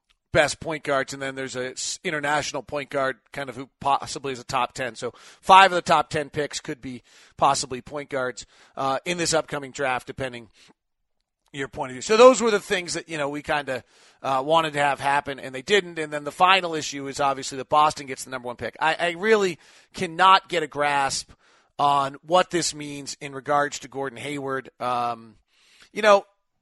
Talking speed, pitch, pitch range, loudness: 205 wpm, 145 Hz, 135-160 Hz, -23 LUFS